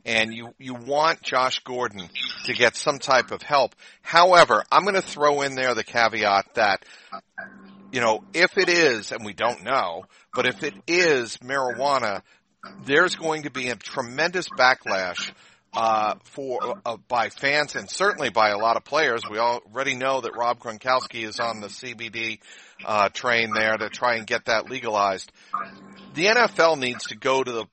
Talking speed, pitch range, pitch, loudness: 175 wpm, 115-135 Hz, 125 Hz, -22 LUFS